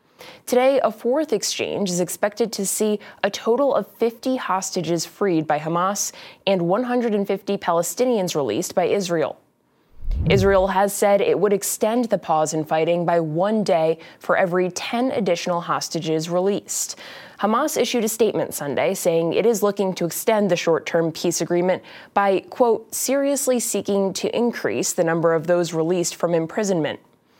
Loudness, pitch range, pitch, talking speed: -21 LUFS, 170-225 Hz, 195 Hz, 150 wpm